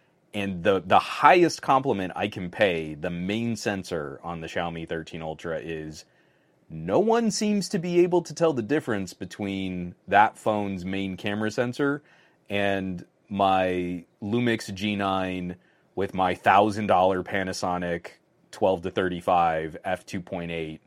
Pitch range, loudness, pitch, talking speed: 90-110 Hz, -26 LUFS, 95 Hz, 140 wpm